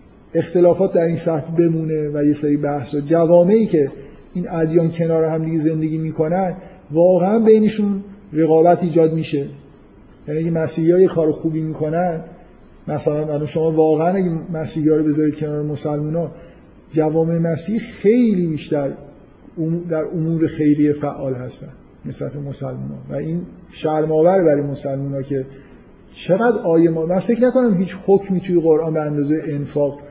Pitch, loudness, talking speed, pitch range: 160 Hz, -18 LUFS, 150 wpm, 150-175 Hz